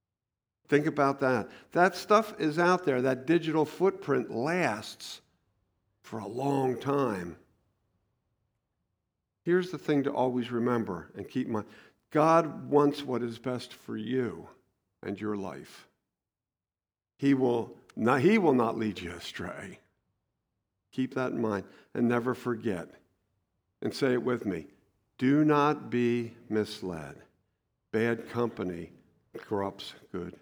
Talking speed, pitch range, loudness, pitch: 130 wpm, 105-140 Hz, -29 LUFS, 120 Hz